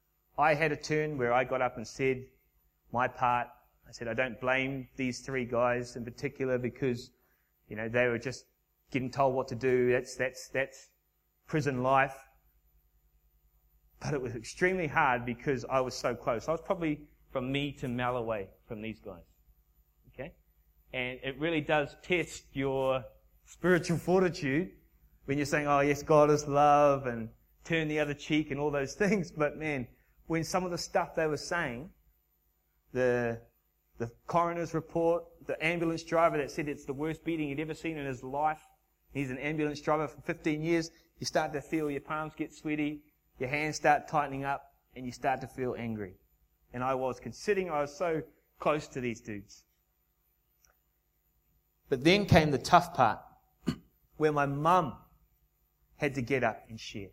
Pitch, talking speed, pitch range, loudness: 135 Hz, 175 wpm, 120-155 Hz, -31 LUFS